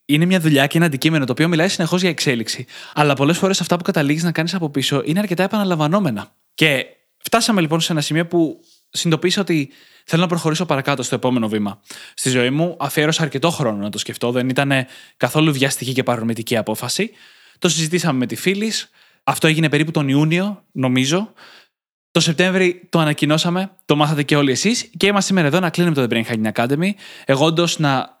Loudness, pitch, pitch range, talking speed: -18 LUFS, 155 Hz, 135-180 Hz, 190 wpm